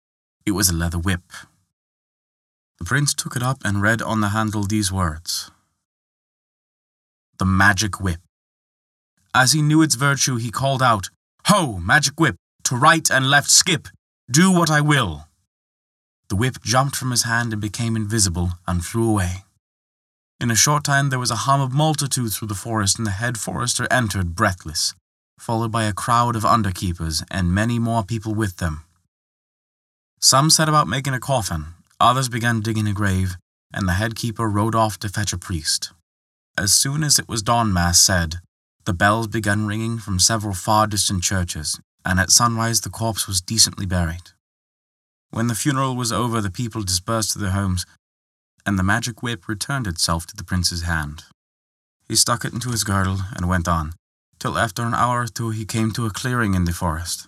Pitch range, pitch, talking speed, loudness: 90-120 Hz, 105 Hz, 180 wpm, -19 LUFS